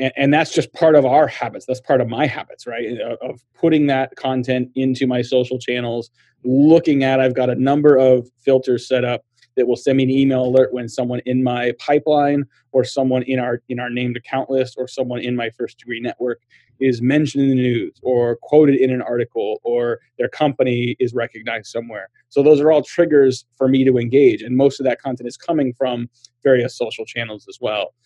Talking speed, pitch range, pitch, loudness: 205 wpm, 125-140 Hz, 130 Hz, -18 LUFS